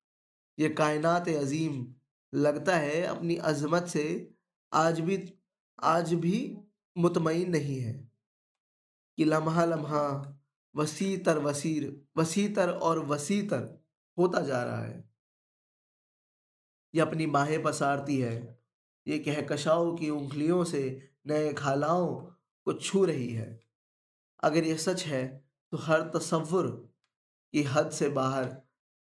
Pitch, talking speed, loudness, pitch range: 155 Hz, 115 wpm, -30 LUFS, 140-170 Hz